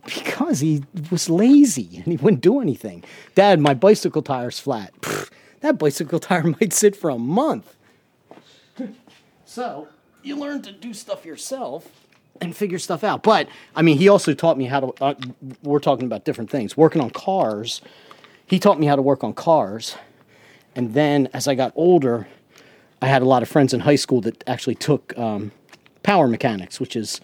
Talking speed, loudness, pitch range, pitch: 185 wpm, -19 LUFS, 130-195 Hz, 155 Hz